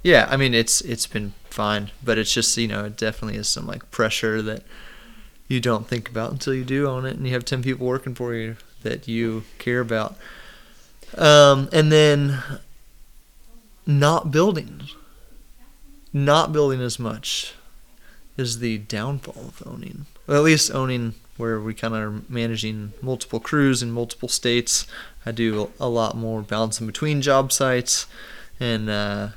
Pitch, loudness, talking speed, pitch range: 120 Hz, -21 LUFS, 165 wpm, 110-135 Hz